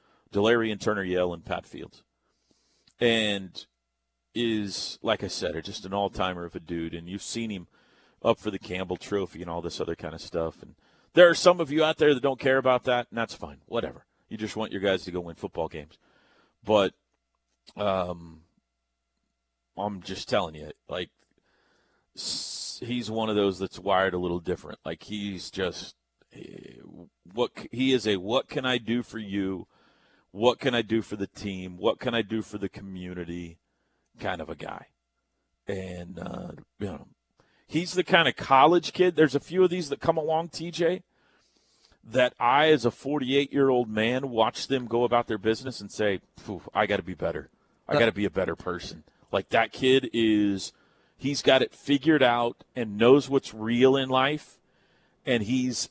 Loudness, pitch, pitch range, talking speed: -27 LUFS, 110 Hz, 95-130 Hz, 185 wpm